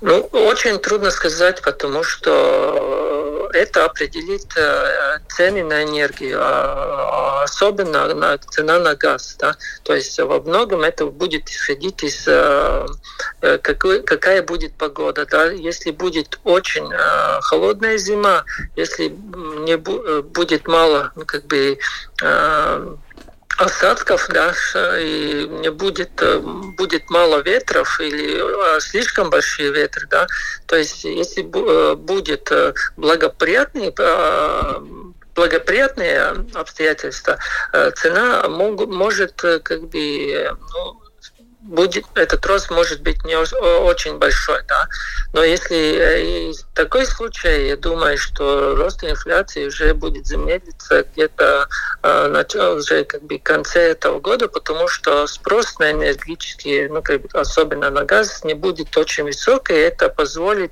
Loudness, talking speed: -17 LUFS, 115 wpm